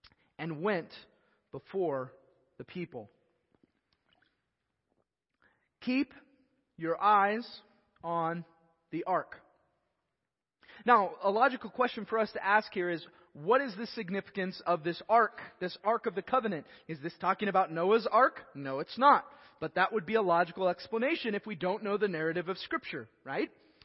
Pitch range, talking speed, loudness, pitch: 175-230 Hz, 145 wpm, -31 LUFS, 205 Hz